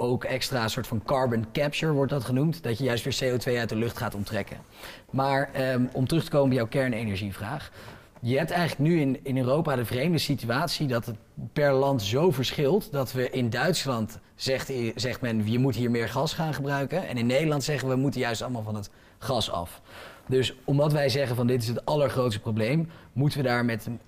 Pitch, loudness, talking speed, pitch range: 130 Hz, -27 LUFS, 210 wpm, 115-140 Hz